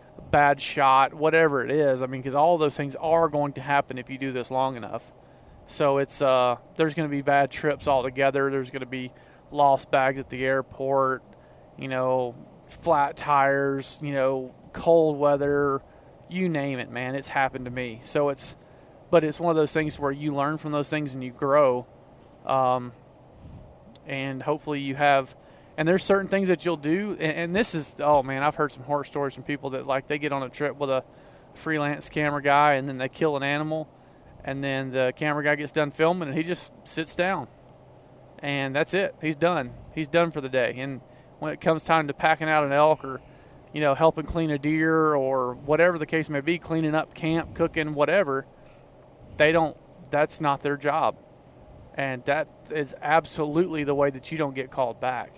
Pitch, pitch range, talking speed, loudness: 145 Hz, 135-155 Hz, 200 wpm, -25 LUFS